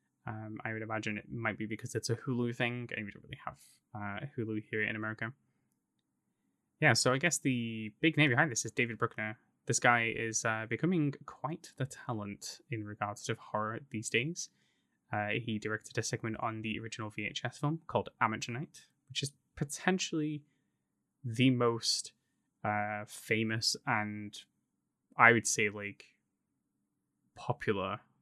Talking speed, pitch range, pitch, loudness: 155 wpm, 110-130 Hz, 115 Hz, -34 LUFS